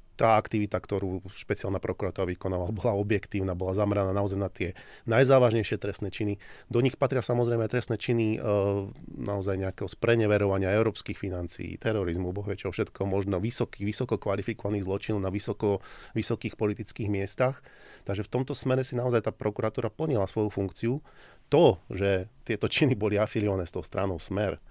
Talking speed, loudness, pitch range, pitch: 155 wpm, -29 LUFS, 100-115 Hz, 105 Hz